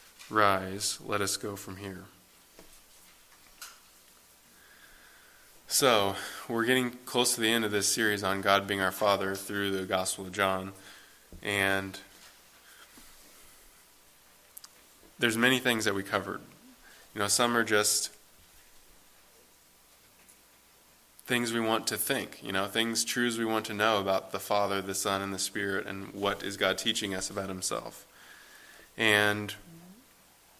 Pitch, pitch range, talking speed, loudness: 100 Hz, 95-115 Hz, 135 wpm, -29 LUFS